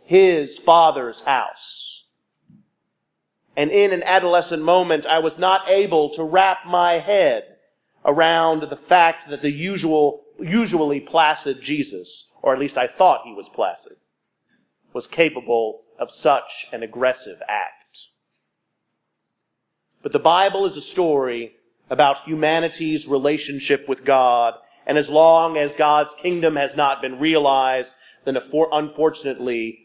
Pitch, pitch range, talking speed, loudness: 155 Hz, 140-175 Hz, 125 wpm, -19 LUFS